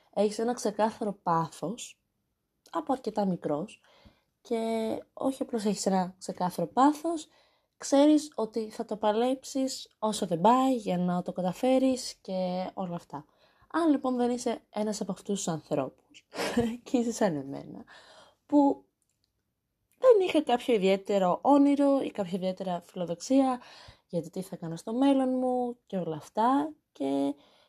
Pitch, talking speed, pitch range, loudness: 220 Hz, 135 wpm, 185-260 Hz, -29 LUFS